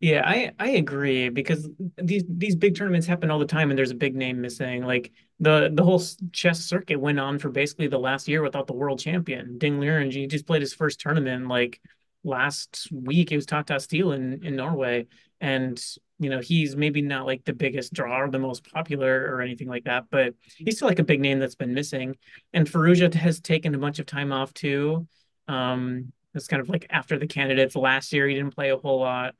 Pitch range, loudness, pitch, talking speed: 130-160 Hz, -25 LUFS, 145 Hz, 220 wpm